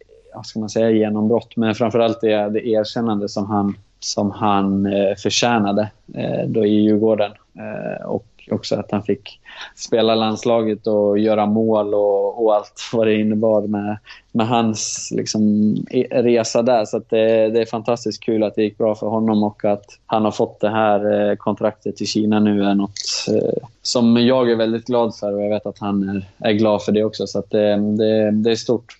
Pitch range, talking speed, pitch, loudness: 105-110 Hz, 195 wpm, 110 Hz, -19 LUFS